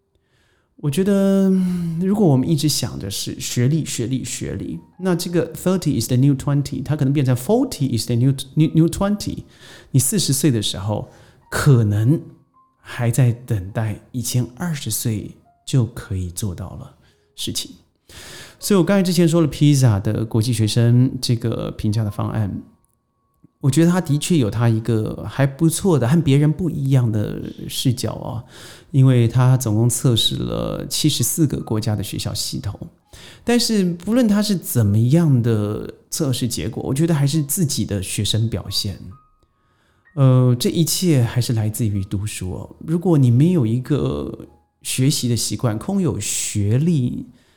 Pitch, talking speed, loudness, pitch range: 130 Hz, 280 characters per minute, -19 LUFS, 115-160 Hz